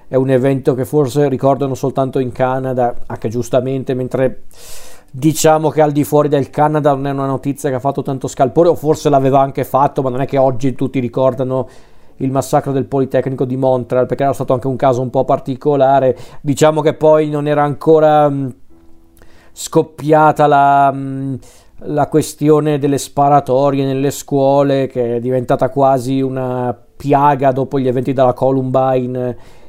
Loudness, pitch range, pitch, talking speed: -14 LUFS, 130-145 Hz, 135 Hz, 160 wpm